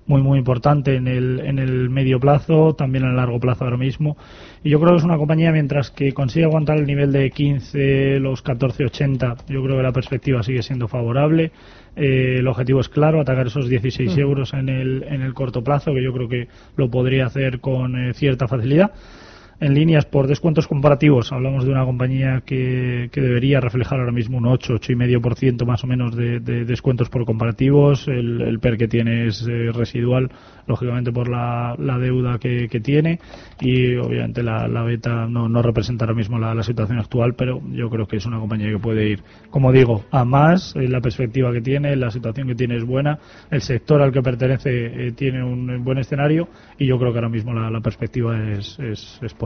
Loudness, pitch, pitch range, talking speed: -19 LUFS, 130 Hz, 120-140 Hz, 205 wpm